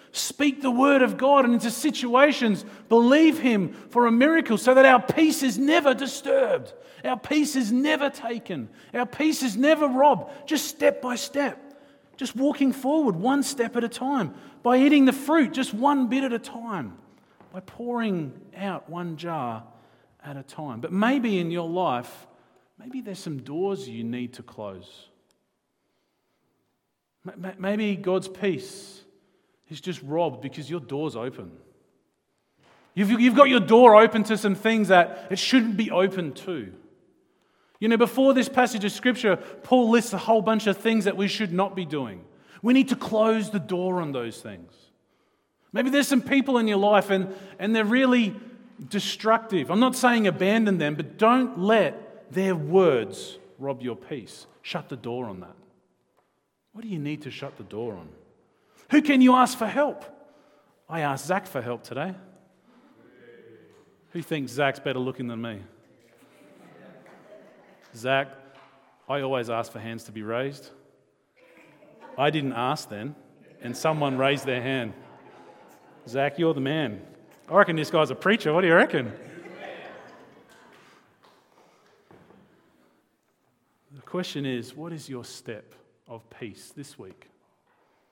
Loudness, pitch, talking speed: -23 LUFS, 200 Hz, 155 wpm